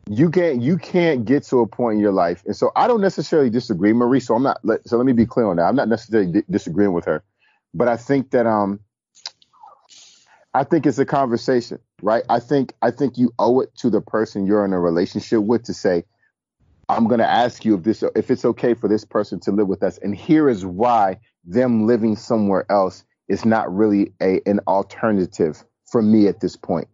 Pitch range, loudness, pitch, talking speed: 105-130 Hz, -19 LUFS, 115 Hz, 220 wpm